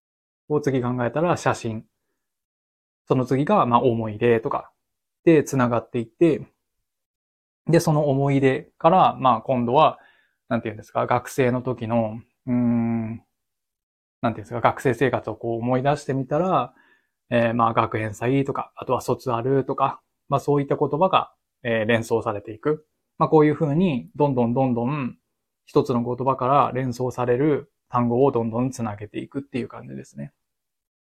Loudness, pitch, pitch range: -22 LUFS, 125 Hz, 115-140 Hz